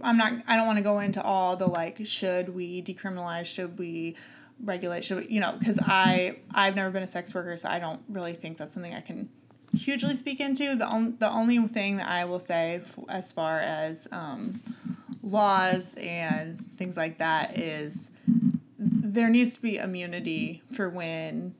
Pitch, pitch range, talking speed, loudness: 190 Hz, 175-225 Hz, 190 wpm, -28 LUFS